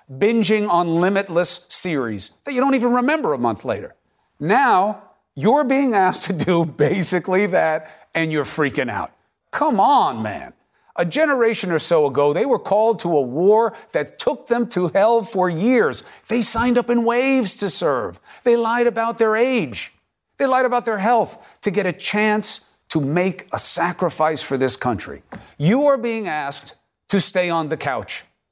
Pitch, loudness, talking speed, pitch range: 205 Hz, -19 LUFS, 175 wpm, 170-235 Hz